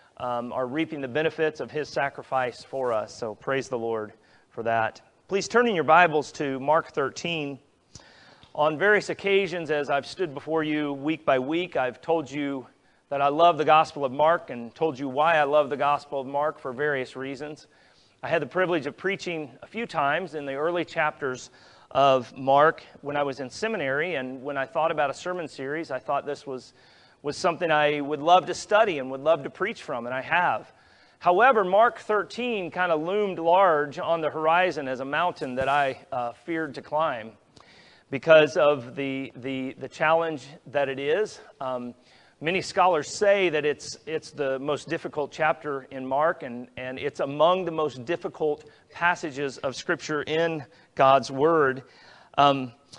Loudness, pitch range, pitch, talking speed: -25 LUFS, 135-165 Hz, 150 Hz, 180 wpm